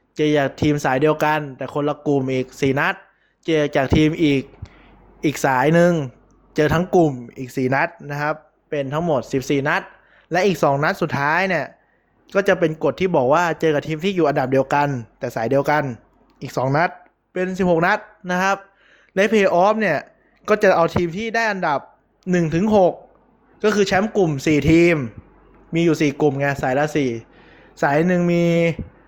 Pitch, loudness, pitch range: 155 Hz, -19 LUFS, 140-180 Hz